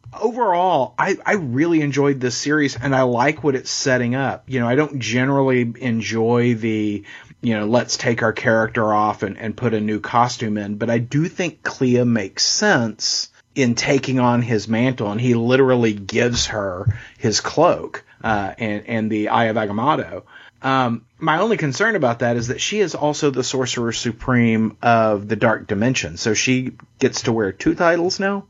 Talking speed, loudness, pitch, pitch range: 185 wpm, -19 LUFS, 120 Hz, 110-135 Hz